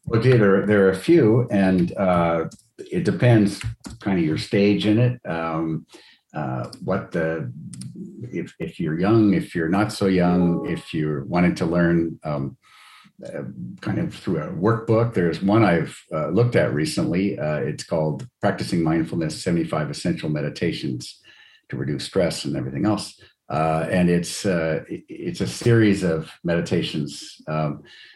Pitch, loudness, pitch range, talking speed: 85 Hz, -22 LUFS, 80-105 Hz, 160 wpm